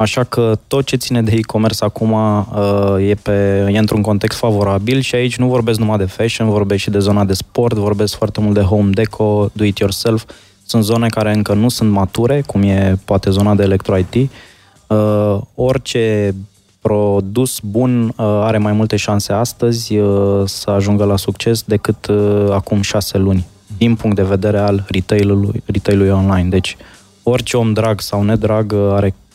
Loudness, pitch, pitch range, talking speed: -14 LUFS, 105 Hz, 100-110 Hz, 175 wpm